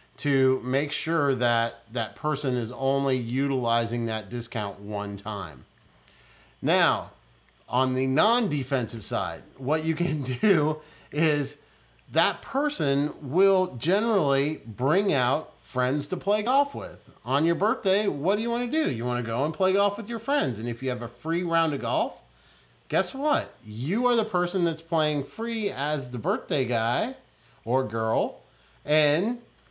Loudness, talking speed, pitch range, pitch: -26 LUFS, 160 wpm, 120-190 Hz, 145 Hz